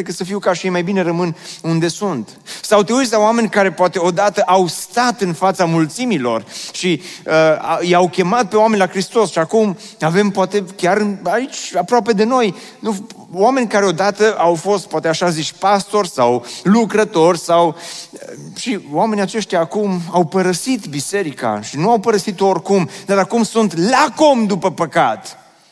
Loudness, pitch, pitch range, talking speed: -16 LUFS, 190 Hz, 175-215 Hz, 170 wpm